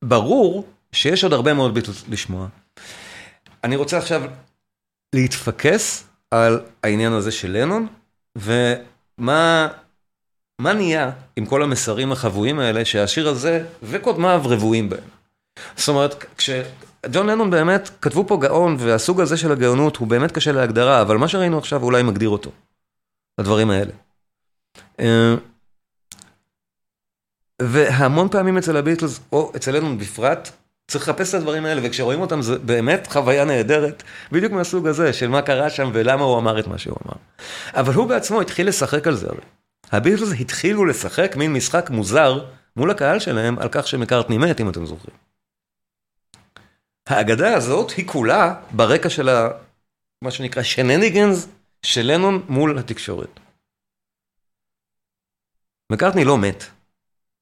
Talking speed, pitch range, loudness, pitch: 130 wpm, 110-155 Hz, -19 LUFS, 130 Hz